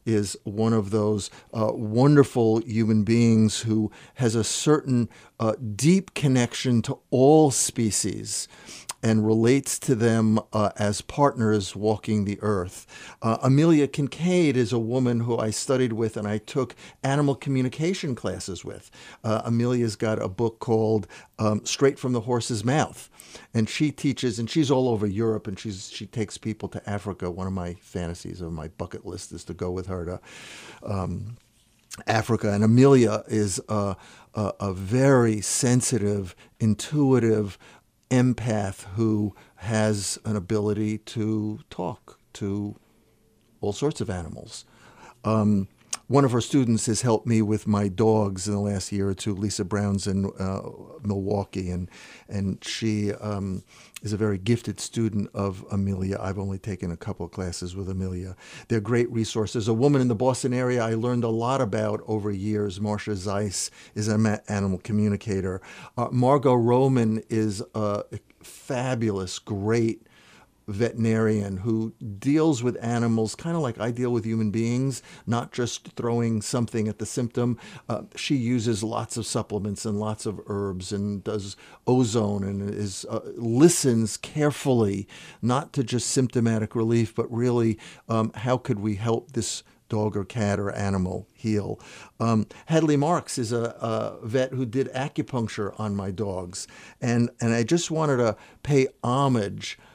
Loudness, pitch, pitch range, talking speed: -25 LUFS, 110 Hz, 105-125 Hz, 155 wpm